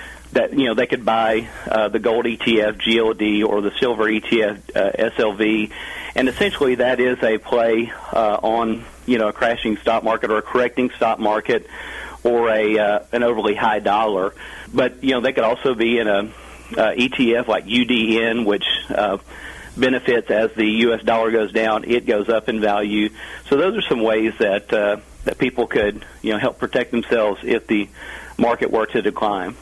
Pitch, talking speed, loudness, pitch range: 110 Hz, 185 wpm, -19 LUFS, 105-115 Hz